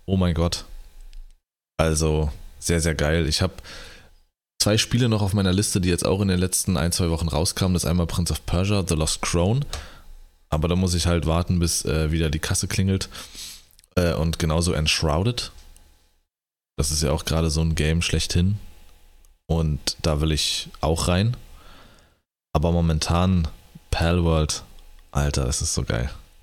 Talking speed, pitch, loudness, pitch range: 170 wpm, 80 Hz, -23 LUFS, 75-90 Hz